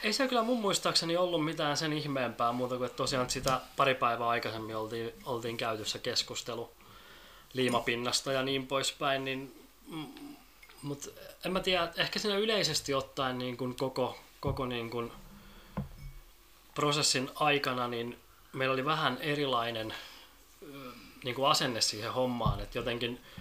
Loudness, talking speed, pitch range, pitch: -32 LUFS, 140 wpm, 120-150 Hz, 130 Hz